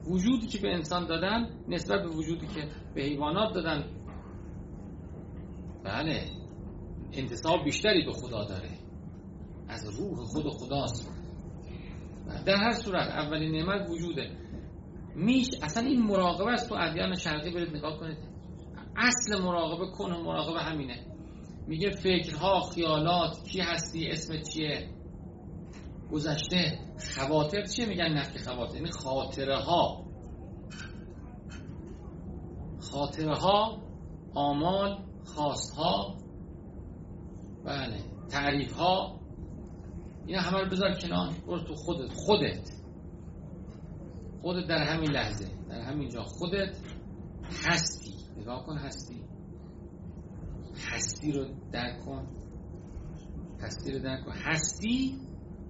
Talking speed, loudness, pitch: 110 wpm, -31 LUFS, 150 Hz